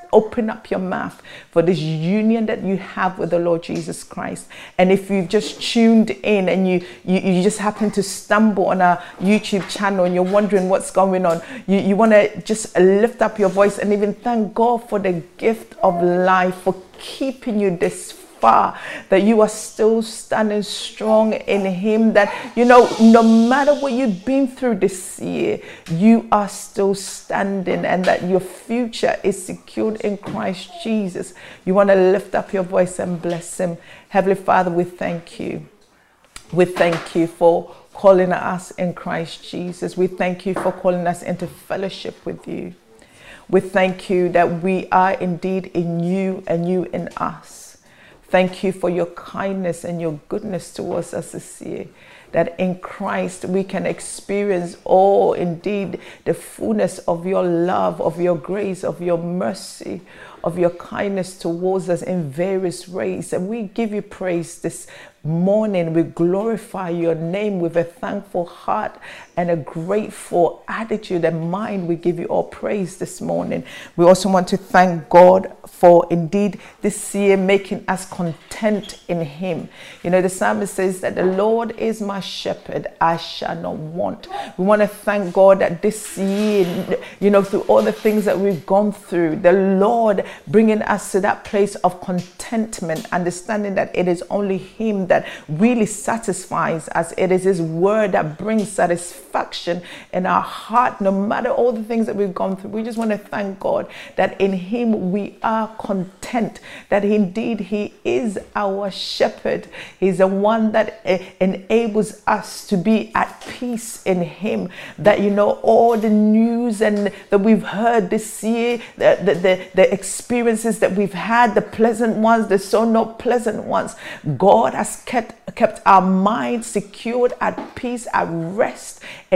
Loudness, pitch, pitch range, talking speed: -19 LUFS, 195 Hz, 180-215 Hz, 170 wpm